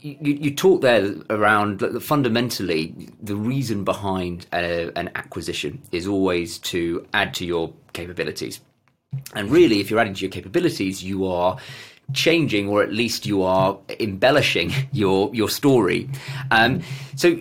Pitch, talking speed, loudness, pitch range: 105 Hz, 145 wpm, -21 LUFS, 95-135 Hz